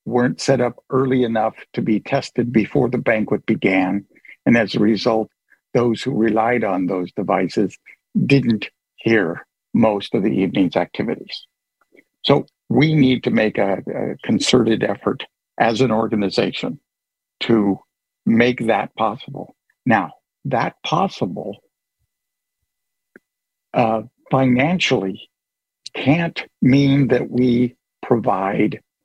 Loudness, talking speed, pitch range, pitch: -19 LUFS, 115 wpm, 110-130 Hz, 120 Hz